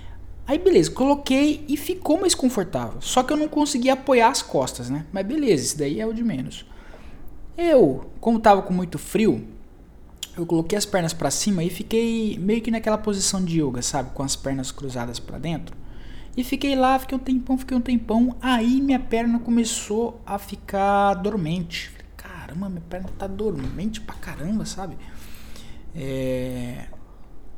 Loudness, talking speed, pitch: -23 LUFS, 170 wpm, 200 Hz